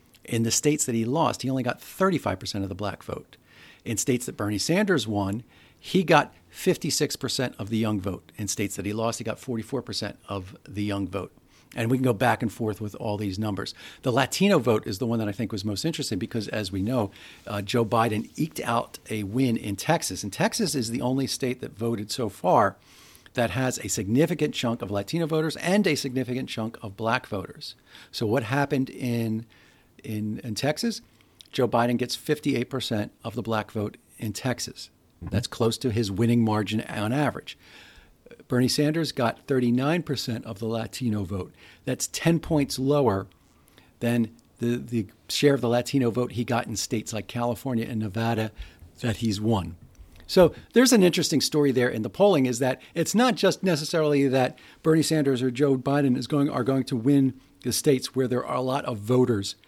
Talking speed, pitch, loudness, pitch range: 195 wpm, 120 Hz, -26 LUFS, 110-135 Hz